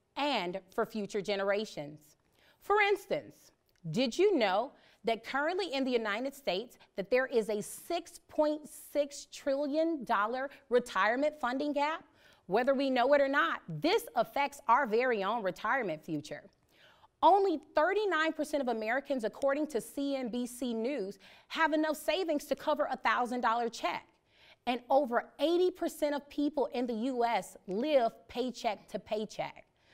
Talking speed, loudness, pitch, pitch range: 130 wpm, -32 LUFS, 265 Hz, 230-300 Hz